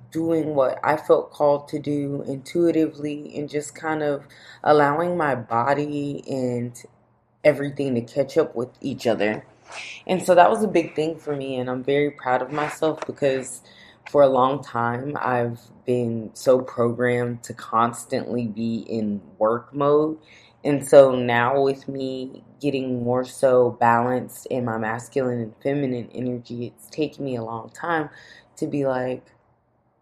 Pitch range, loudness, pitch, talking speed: 120-145 Hz, -23 LUFS, 130 Hz, 155 wpm